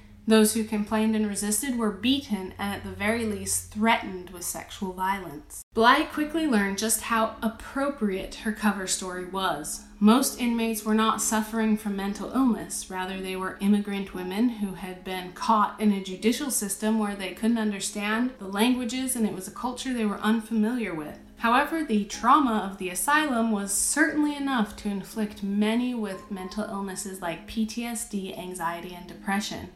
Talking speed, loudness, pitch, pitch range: 165 wpm, -26 LUFS, 215 Hz, 195-230 Hz